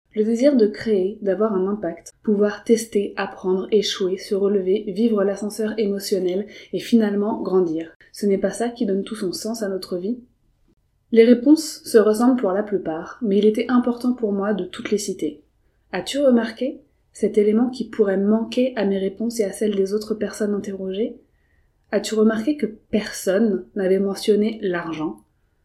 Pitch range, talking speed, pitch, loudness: 190-225 Hz, 175 wpm, 210 Hz, -21 LUFS